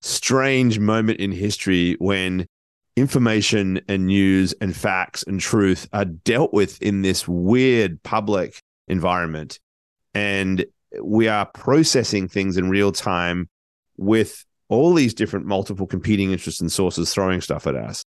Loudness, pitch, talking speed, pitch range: -20 LUFS, 100 Hz, 135 wpm, 95-105 Hz